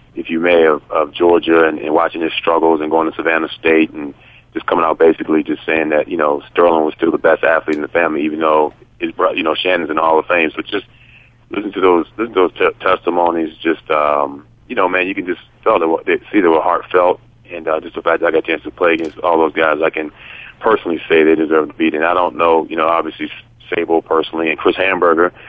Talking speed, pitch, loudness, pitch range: 255 wpm, 80 Hz, -15 LUFS, 80-85 Hz